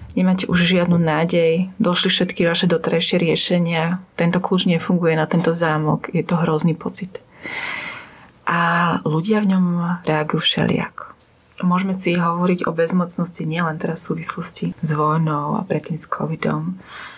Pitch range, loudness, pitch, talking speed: 165-180 Hz, -19 LUFS, 170 Hz, 140 wpm